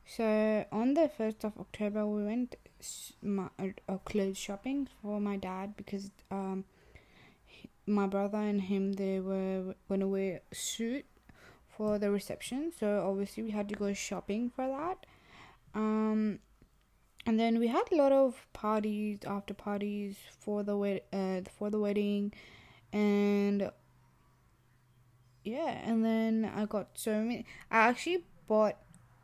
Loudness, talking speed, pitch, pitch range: -34 LUFS, 140 wpm, 205 Hz, 195-220 Hz